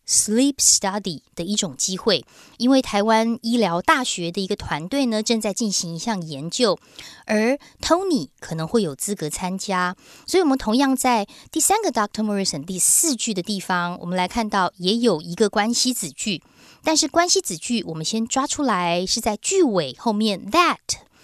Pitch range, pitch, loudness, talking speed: 180-255 Hz, 215 Hz, -21 LUFS, 325 characters per minute